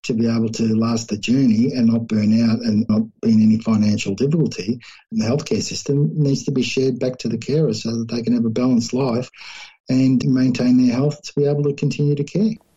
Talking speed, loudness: 230 wpm, -19 LUFS